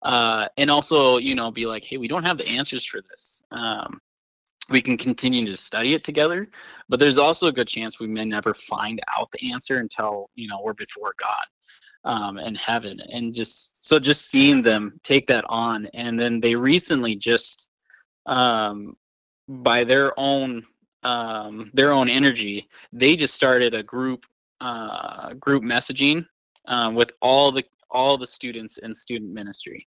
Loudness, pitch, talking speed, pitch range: -21 LUFS, 120 Hz, 170 wpm, 115-135 Hz